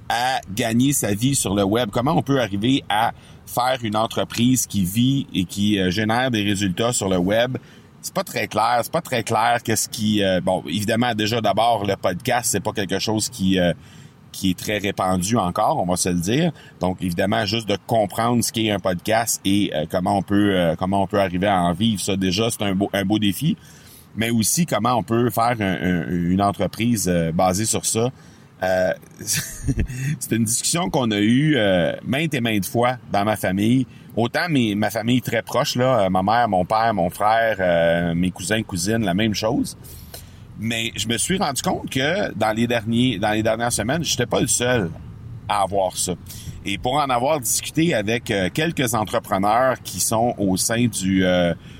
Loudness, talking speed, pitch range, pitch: -21 LUFS, 200 wpm, 95-120 Hz, 110 Hz